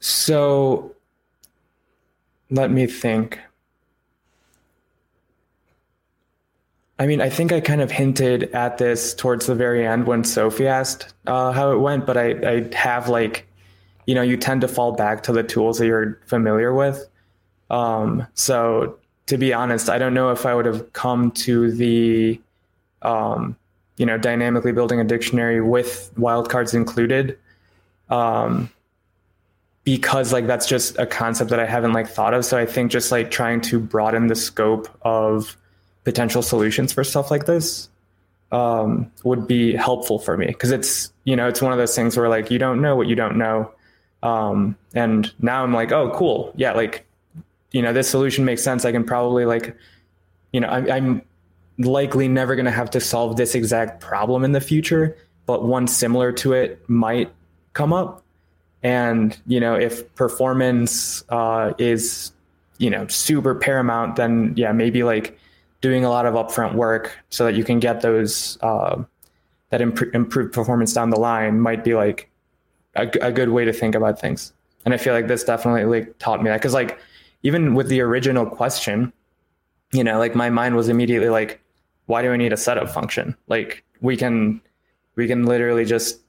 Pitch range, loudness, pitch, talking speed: 110-125 Hz, -20 LUFS, 120 Hz, 175 wpm